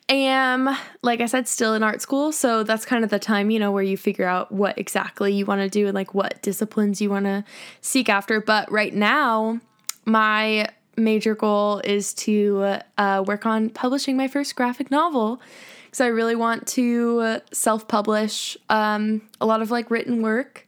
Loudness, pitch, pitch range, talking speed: -22 LUFS, 220 Hz, 205-240 Hz, 190 wpm